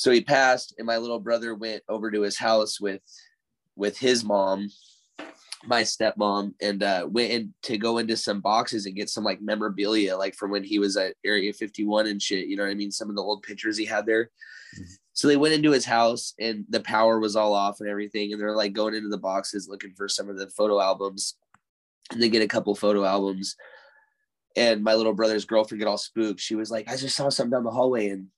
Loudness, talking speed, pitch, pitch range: -25 LUFS, 230 wpm, 110 Hz, 100-115 Hz